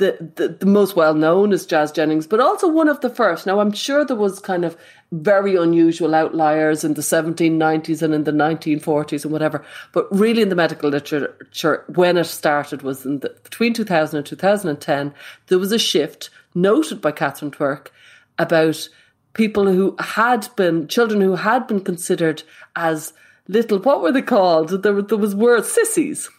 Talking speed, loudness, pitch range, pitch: 180 wpm, -18 LUFS, 155-205 Hz, 170 Hz